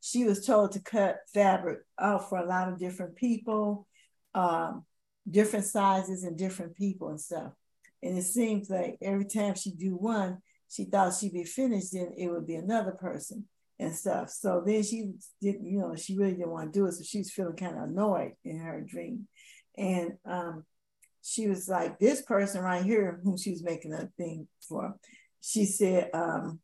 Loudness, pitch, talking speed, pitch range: -31 LUFS, 195 Hz, 190 wpm, 180-205 Hz